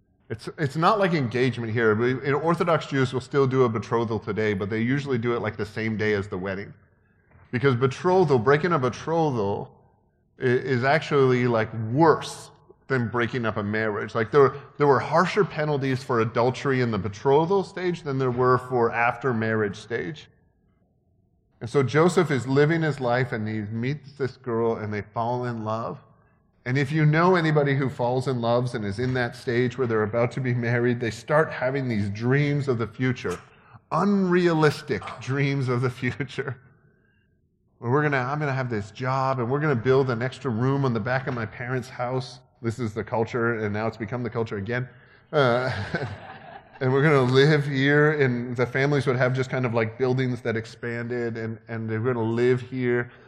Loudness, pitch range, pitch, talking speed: -24 LUFS, 115-140 Hz, 125 Hz, 190 wpm